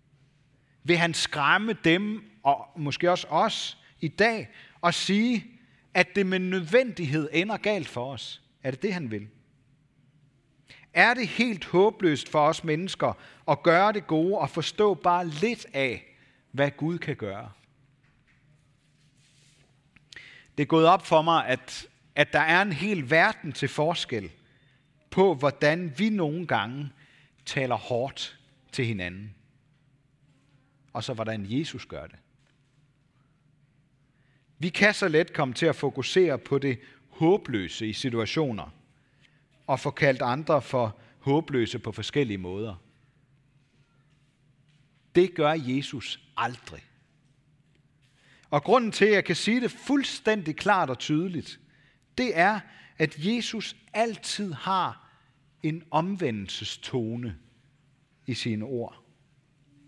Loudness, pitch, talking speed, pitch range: -26 LUFS, 145 Hz, 125 wpm, 135-170 Hz